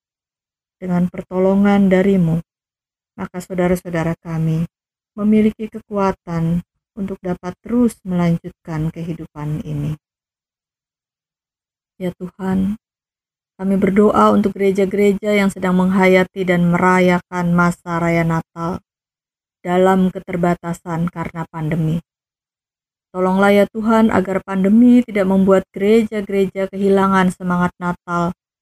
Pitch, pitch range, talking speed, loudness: 185 Hz, 170-195 Hz, 90 wpm, -17 LUFS